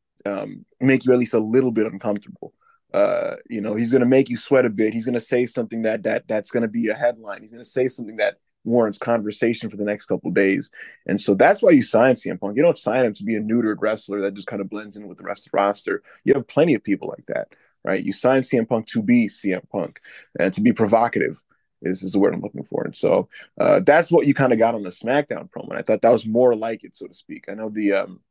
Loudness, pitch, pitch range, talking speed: -21 LUFS, 115 Hz, 105-125 Hz, 270 wpm